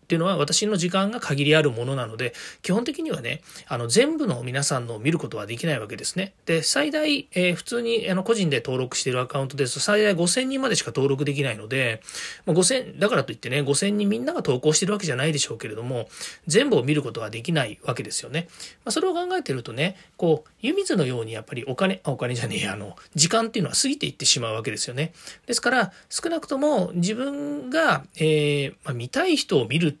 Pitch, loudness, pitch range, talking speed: 165 Hz, -24 LUFS, 140-220 Hz, 455 characters per minute